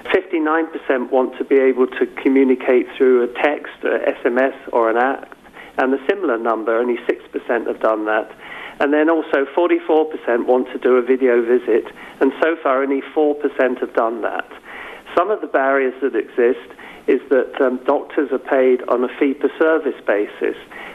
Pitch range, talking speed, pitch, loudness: 125-160 Hz, 165 wpm, 135 Hz, -18 LUFS